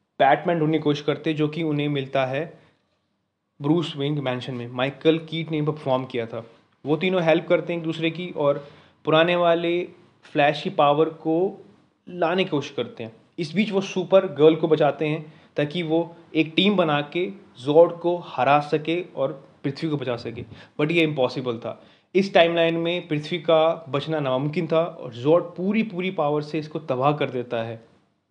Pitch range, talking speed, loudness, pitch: 140-170 Hz, 180 wpm, -23 LUFS, 155 Hz